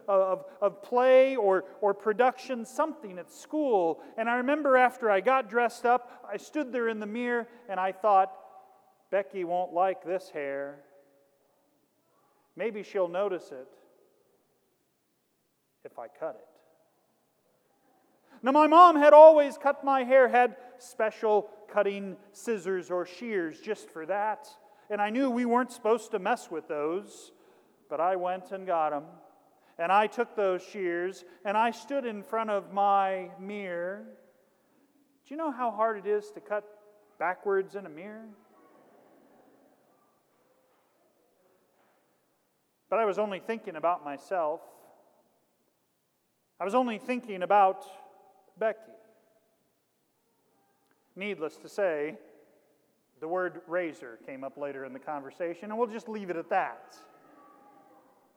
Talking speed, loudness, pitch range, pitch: 135 wpm, -27 LUFS, 185-245 Hz, 210 Hz